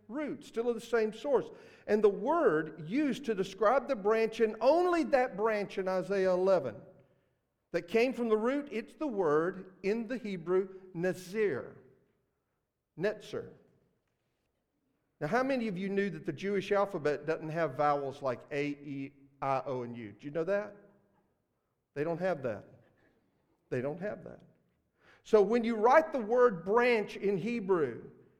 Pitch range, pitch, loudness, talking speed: 170-235 Hz, 205 Hz, -32 LUFS, 160 wpm